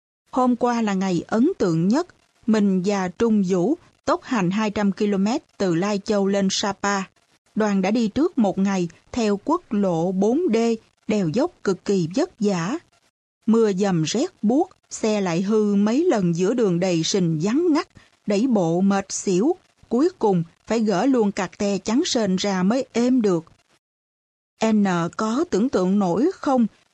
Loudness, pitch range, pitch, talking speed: -22 LUFS, 190-245 Hz, 210 Hz, 165 wpm